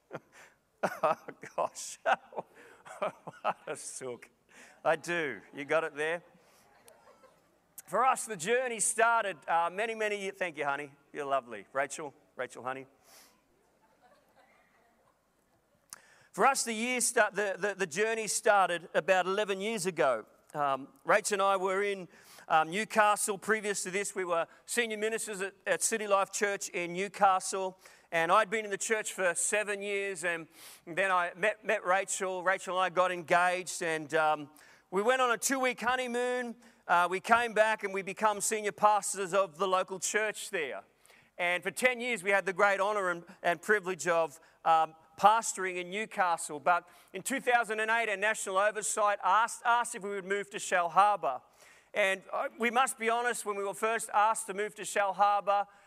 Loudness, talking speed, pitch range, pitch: -30 LUFS, 165 wpm, 180-215 Hz, 195 Hz